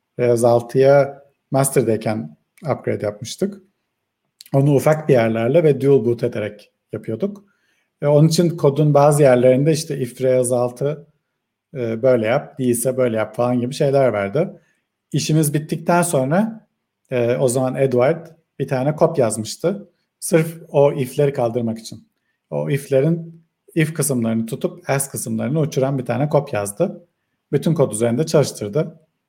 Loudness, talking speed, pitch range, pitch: -18 LUFS, 135 wpm, 120-155 Hz, 135 Hz